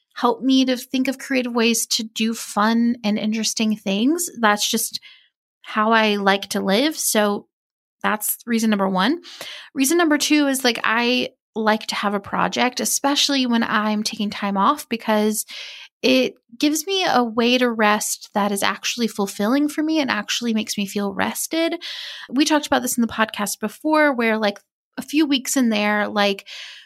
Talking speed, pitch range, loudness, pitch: 175 wpm, 210-275 Hz, -20 LUFS, 230 Hz